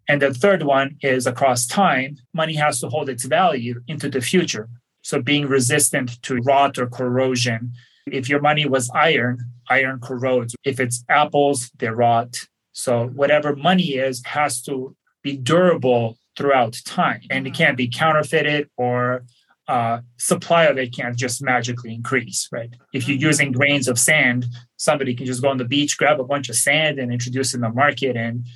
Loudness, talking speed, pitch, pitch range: -19 LUFS, 175 wpm, 130 Hz, 125-145 Hz